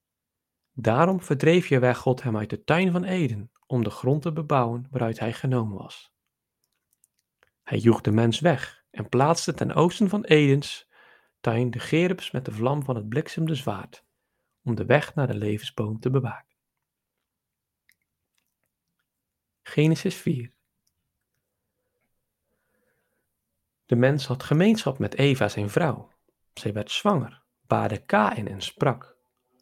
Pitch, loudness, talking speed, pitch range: 130 Hz, -24 LUFS, 135 wpm, 115-155 Hz